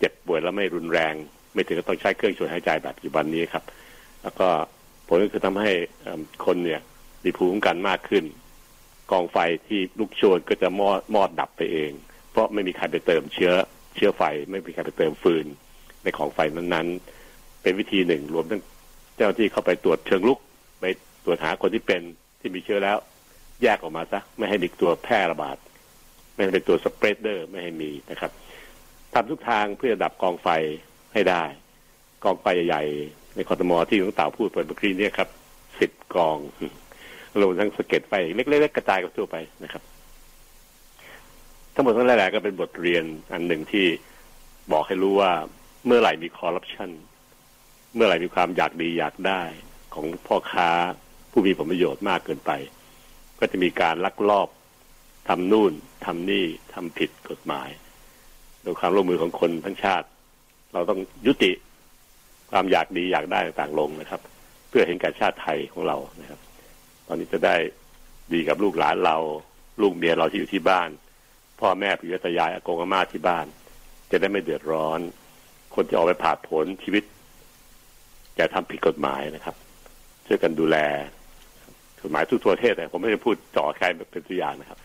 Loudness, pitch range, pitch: -24 LUFS, 75-95 Hz, 85 Hz